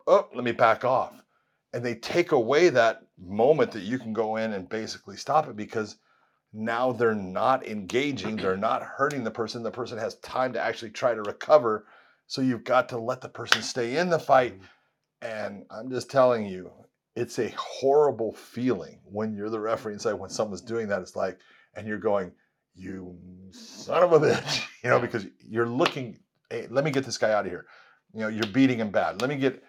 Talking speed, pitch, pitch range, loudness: 210 wpm, 115 Hz, 110-130 Hz, -26 LUFS